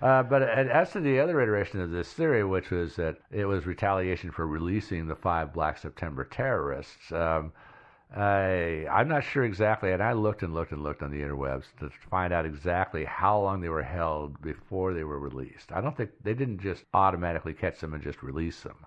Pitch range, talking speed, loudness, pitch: 80-100 Hz, 205 wpm, -29 LUFS, 90 Hz